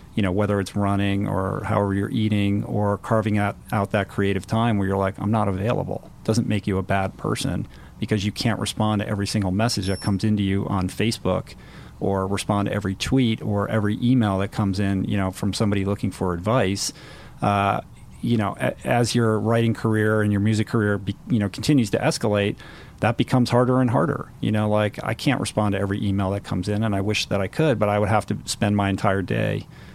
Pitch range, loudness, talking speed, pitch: 100-110 Hz, -23 LUFS, 220 wpm, 105 Hz